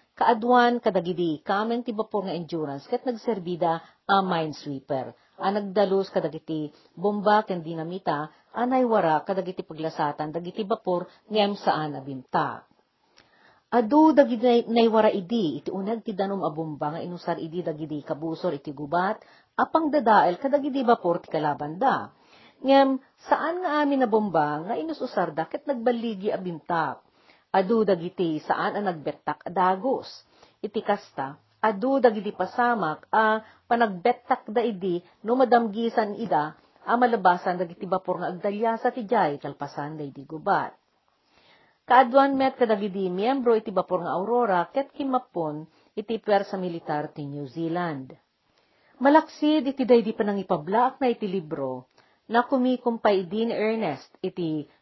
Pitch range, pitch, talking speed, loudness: 165-240 Hz, 200 Hz, 130 wpm, -25 LUFS